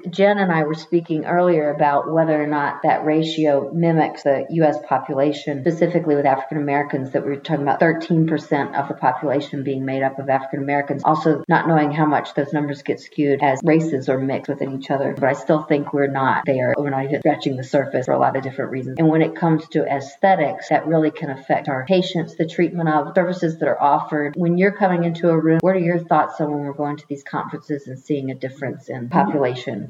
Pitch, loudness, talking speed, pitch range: 150 Hz, -20 LUFS, 225 wpm, 140-160 Hz